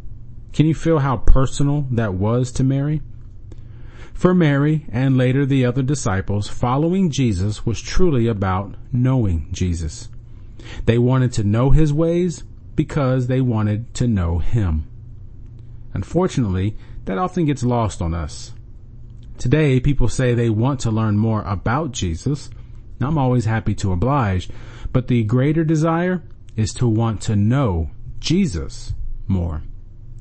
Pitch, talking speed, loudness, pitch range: 115 Hz, 135 wpm, -20 LUFS, 110-135 Hz